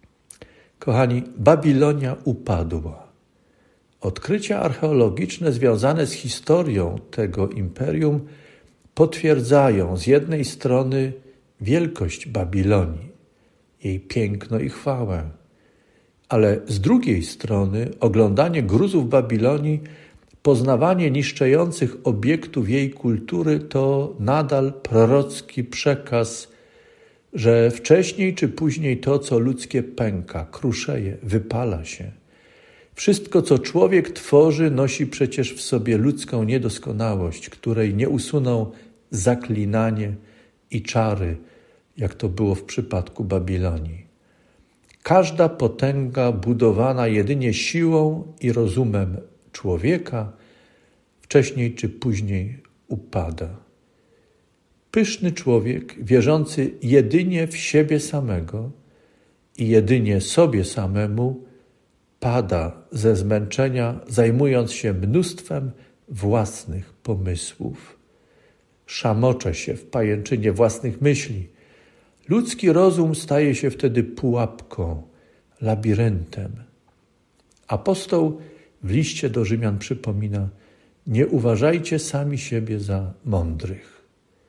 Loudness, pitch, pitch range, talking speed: -21 LUFS, 120 Hz, 105-145 Hz, 90 wpm